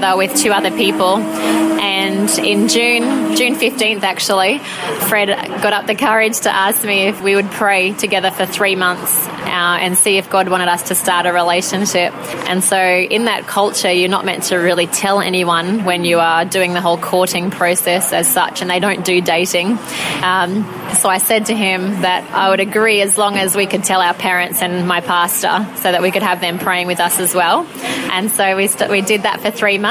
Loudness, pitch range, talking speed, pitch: -14 LUFS, 180-200 Hz, 215 wpm, 190 Hz